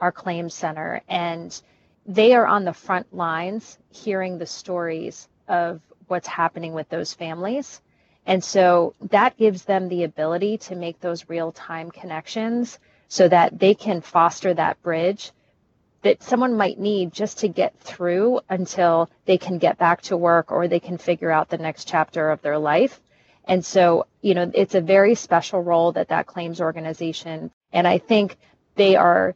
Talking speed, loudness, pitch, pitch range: 170 wpm, -21 LUFS, 175 Hz, 165-195 Hz